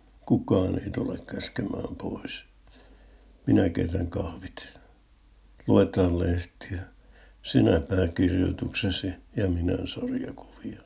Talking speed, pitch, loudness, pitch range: 85 wpm, 95 Hz, -27 LUFS, 90-95 Hz